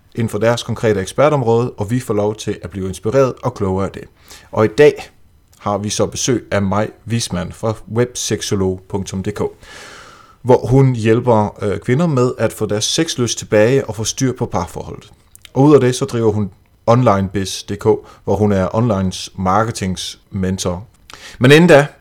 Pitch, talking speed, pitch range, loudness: 110 Hz, 165 wpm, 100-120 Hz, -16 LUFS